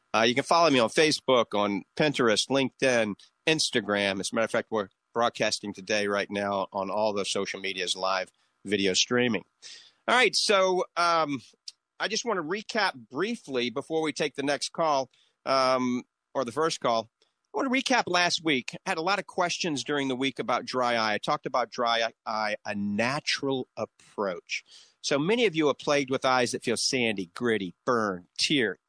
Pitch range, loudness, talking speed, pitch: 105-145 Hz, -27 LUFS, 185 wpm, 125 Hz